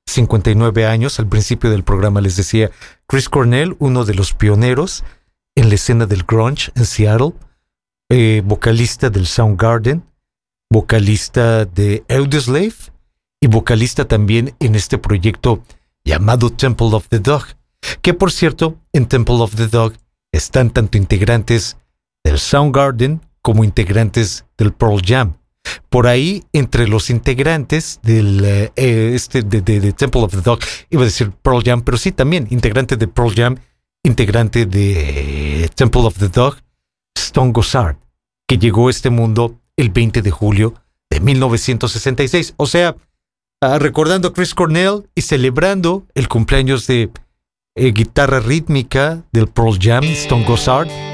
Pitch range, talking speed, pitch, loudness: 110-135 Hz, 140 wpm, 120 Hz, -14 LUFS